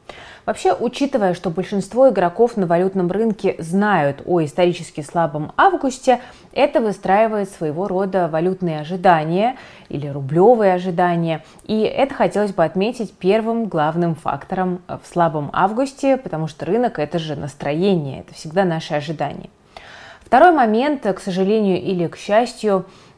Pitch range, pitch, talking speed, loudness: 165-220 Hz, 190 Hz, 130 wpm, -19 LUFS